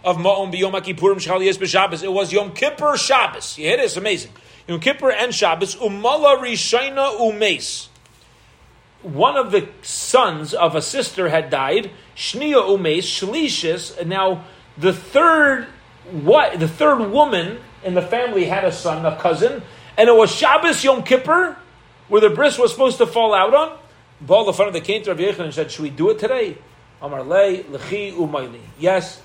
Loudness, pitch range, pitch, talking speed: -17 LUFS, 185-270 Hz, 205 Hz, 175 wpm